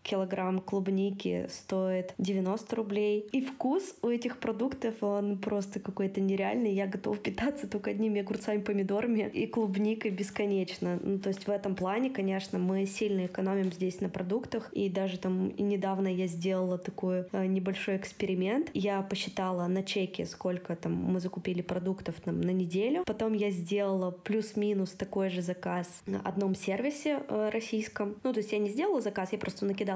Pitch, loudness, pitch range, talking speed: 195 Hz, -32 LUFS, 190-215 Hz, 165 wpm